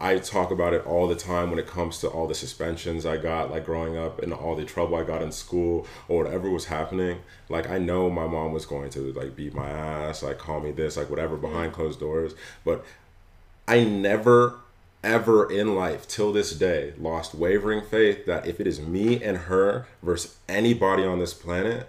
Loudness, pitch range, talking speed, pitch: -26 LUFS, 80-95 Hz, 210 wpm, 85 Hz